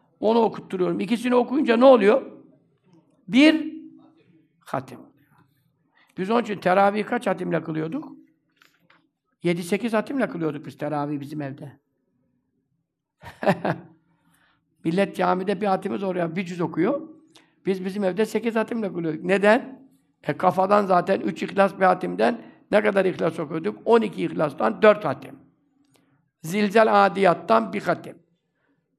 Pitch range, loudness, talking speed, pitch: 160-220 Hz, -22 LUFS, 115 wpm, 190 Hz